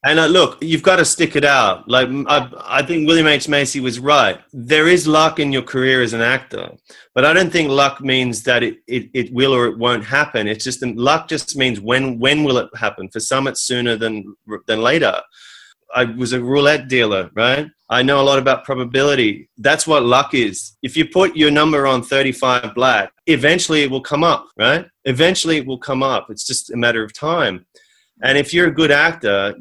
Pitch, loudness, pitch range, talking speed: 135 Hz, -15 LUFS, 125-150 Hz, 230 wpm